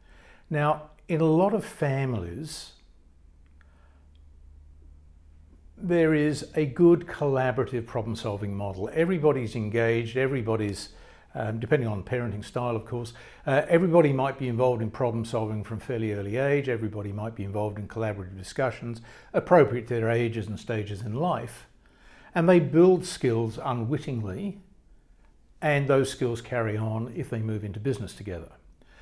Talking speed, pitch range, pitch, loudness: 135 wpm, 105-135 Hz, 115 Hz, -27 LUFS